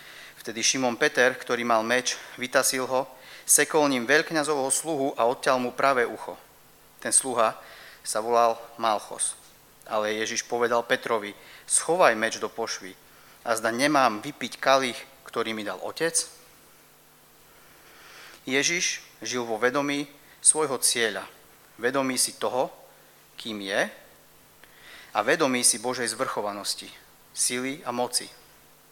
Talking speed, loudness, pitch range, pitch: 120 wpm, -25 LUFS, 115-140 Hz, 125 Hz